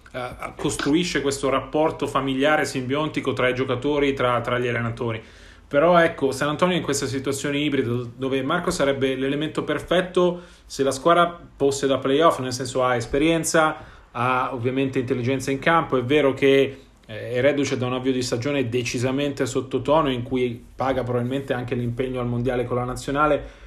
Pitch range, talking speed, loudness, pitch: 125-145 Hz, 165 wpm, -22 LUFS, 135 Hz